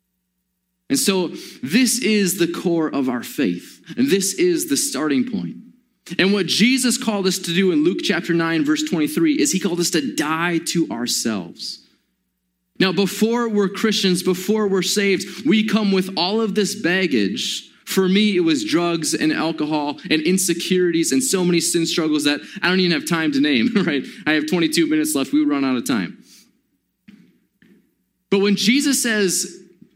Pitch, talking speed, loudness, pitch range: 185 Hz, 175 wpm, -19 LUFS, 165-210 Hz